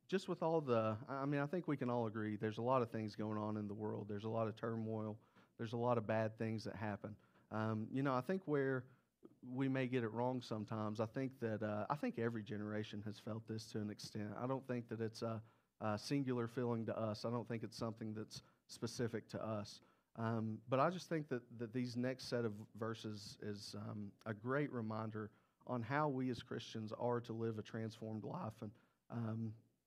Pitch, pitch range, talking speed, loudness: 115 Hz, 110-125 Hz, 225 wpm, -43 LUFS